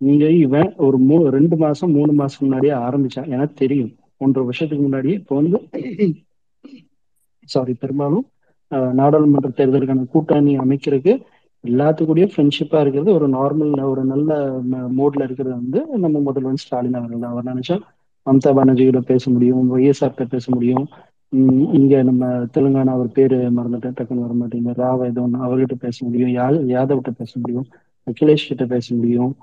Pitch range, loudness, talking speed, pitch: 125-145 Hz, -17 LUFS, 135 wpm, 135 Hz